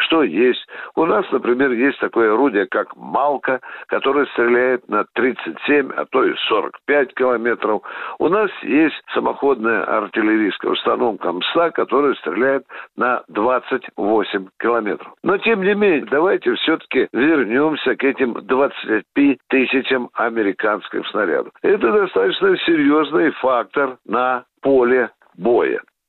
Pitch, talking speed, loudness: 285 Hz, 115 wpm, -18 LUFS